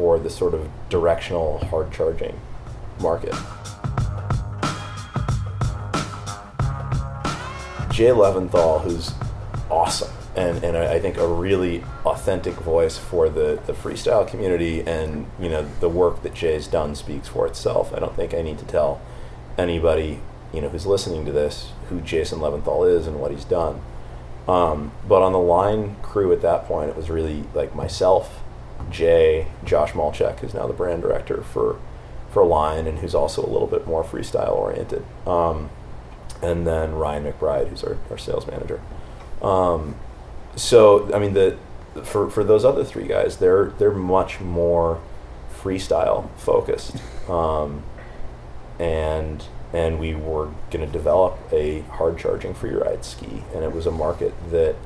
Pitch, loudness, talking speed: 105 Hz, -22 LUFS, 150 wpm